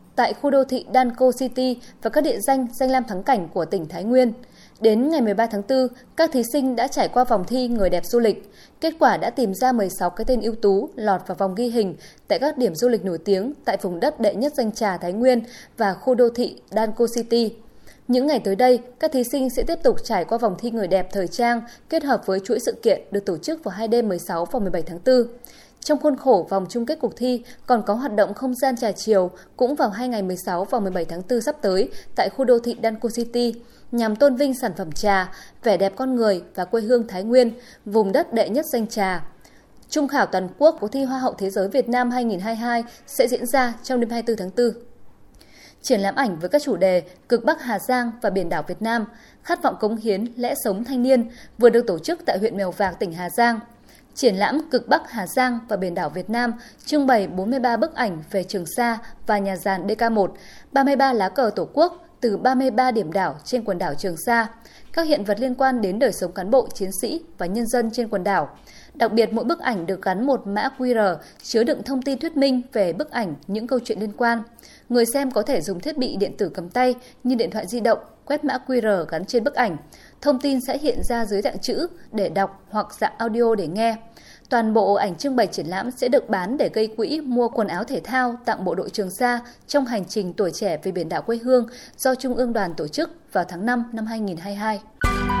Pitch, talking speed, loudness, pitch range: 235 Hz, 240 wpm, -22 LUFS, 200-255 Hz